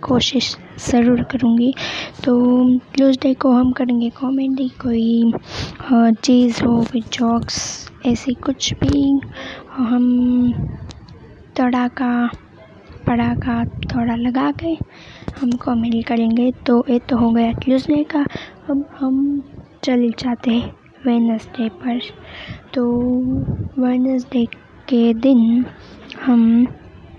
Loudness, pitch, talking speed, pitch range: -18 LUFS, 245 Hz, 105 wpm, 235-260 Hz